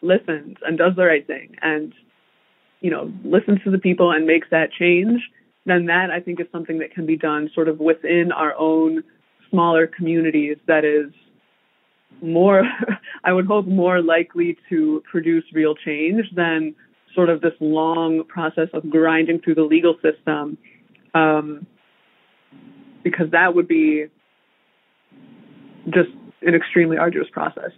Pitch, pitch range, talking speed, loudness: 165 Hz, 160-180 Hz, 145 wpm, -19 LUFS